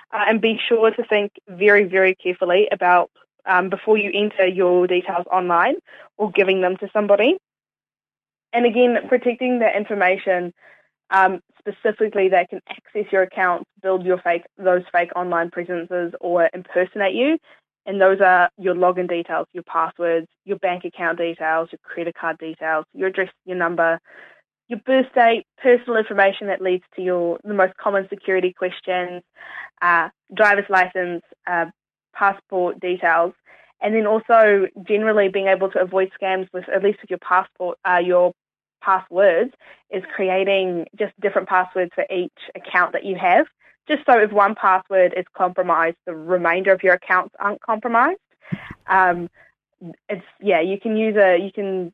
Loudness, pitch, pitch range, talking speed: -19 LUFS, 190 Hz, 180-205 Hz, 160 wpm